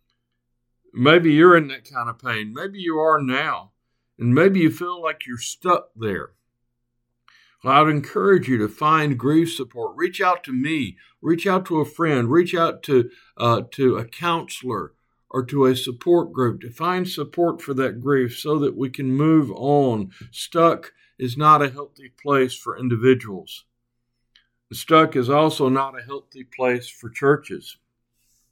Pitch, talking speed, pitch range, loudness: 135 Hz, 165 wpm, 120-160 Hz, -20 LUFS